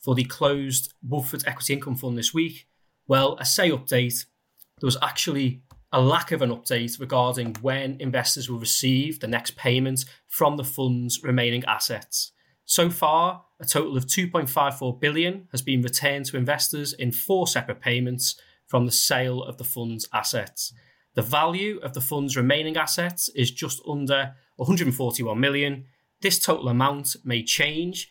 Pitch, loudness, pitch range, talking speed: 135 Hz, -24 LUFS, 125-150 Hz, 160 wpm